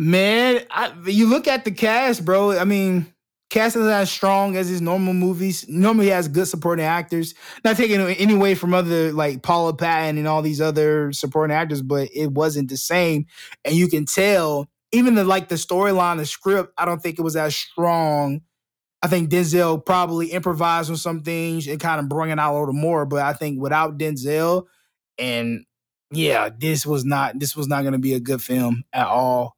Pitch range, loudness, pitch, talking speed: 150-185 Hz, -20 LUFS, 165 Hz, 205 wpm